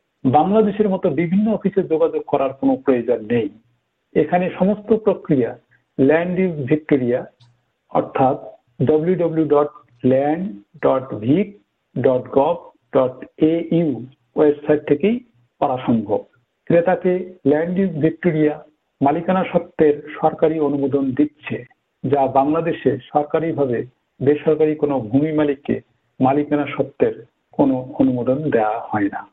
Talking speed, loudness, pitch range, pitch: 80 wpm, -19 LUFS, 140-175 Hz, 150 Hz